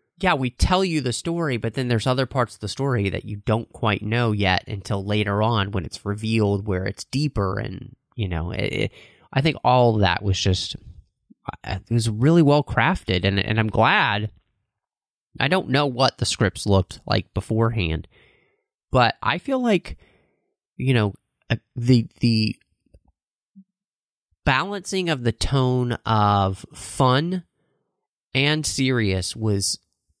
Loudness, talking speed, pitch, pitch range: -22 LUFS, 150 wpm, 115 Hz, 100-135 Hz